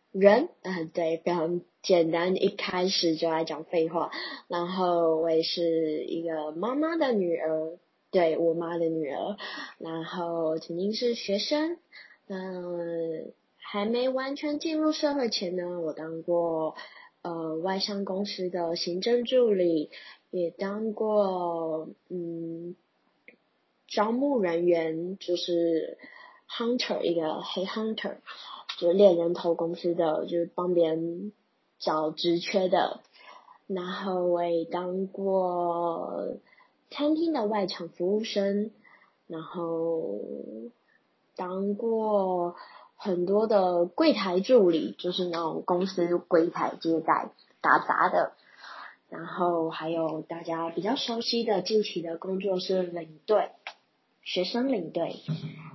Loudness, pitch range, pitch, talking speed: -28 LUFS, 165-200 Hz, 175 Hz, 185 characters per minute